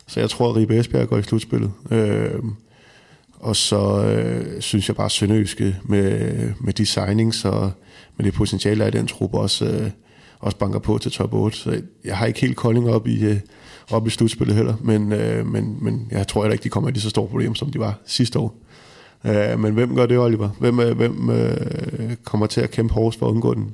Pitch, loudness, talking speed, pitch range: 110 Hz, -20 LUFS, 220 wpm, 105-120 Hz